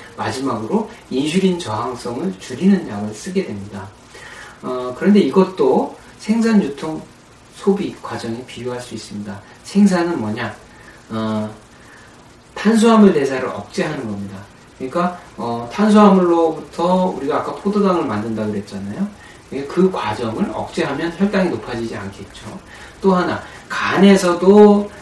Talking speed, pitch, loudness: 290 characters per minute, 165 Hz, -17 LUFS